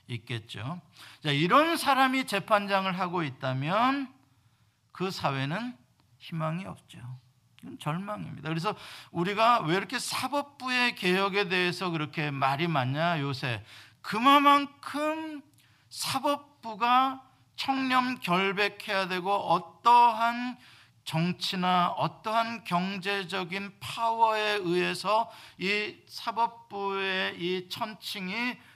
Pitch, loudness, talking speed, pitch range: 190 Hz, -28 LUFS, 225 characters per minute, 160-230 Hz